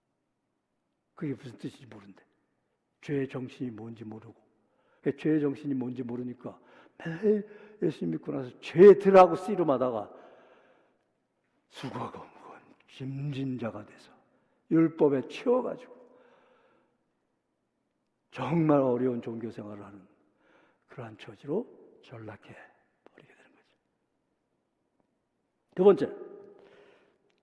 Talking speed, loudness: 220 characters per minute, -27 LUFS